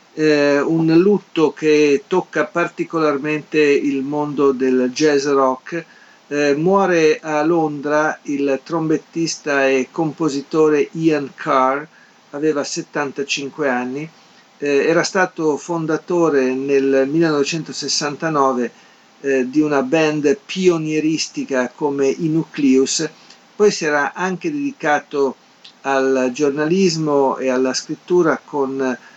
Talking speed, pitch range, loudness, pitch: 100 wpm, 140-165 Hz, -18 LUFS, 150 Hz